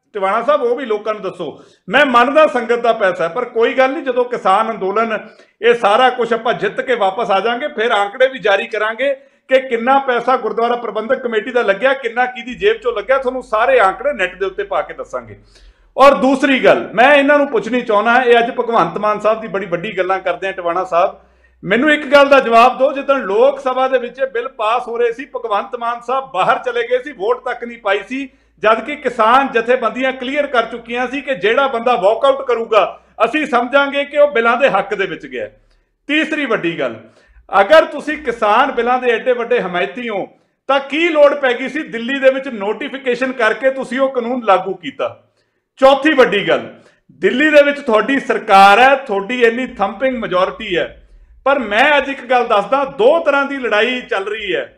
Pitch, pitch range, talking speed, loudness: 250 Hz, 220-275 Hz, 195 wpm, -14 LUFS